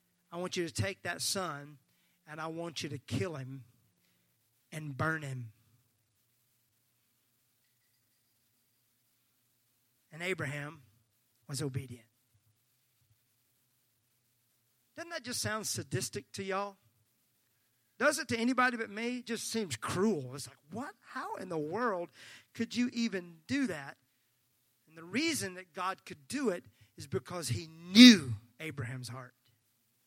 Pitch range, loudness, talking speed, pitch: 120-180 Hz, -32 LUFS, 130 wpm, 125 Hz